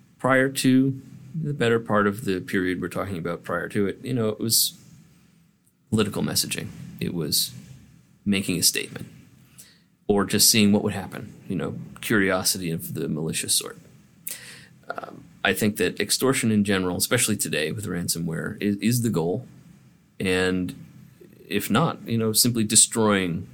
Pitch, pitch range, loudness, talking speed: 110 Hz, 95-130 Hz, -23 LUFS, 155 wpm